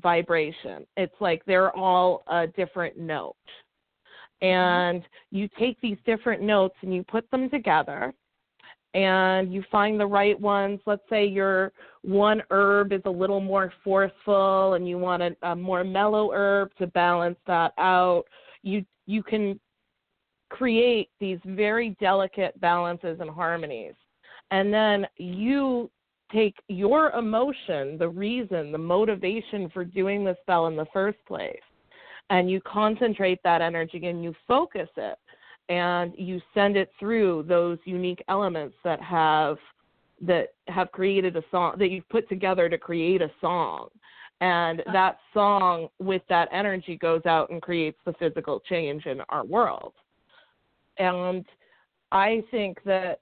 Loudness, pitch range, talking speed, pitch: -25 LUFS, 175-205 Hz, 145 wpm, 190 Hz